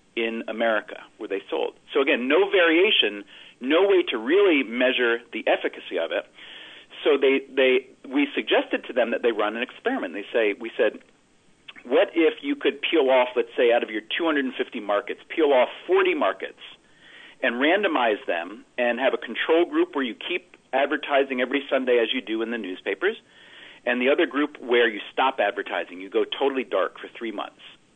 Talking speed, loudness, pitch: 185 wpm, -23 LUFS, 230 Hz